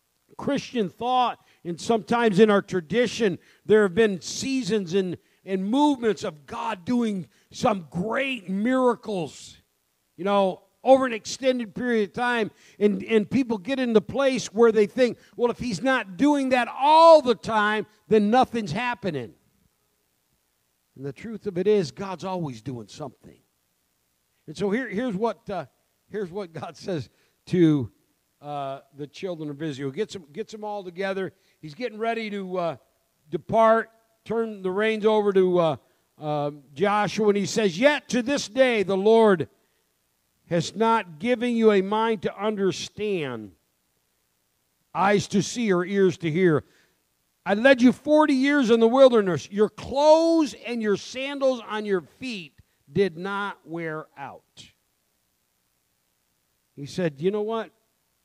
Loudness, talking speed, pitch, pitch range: -23 LUFS, 150 wpm, 200 Hz, 160-230 Hz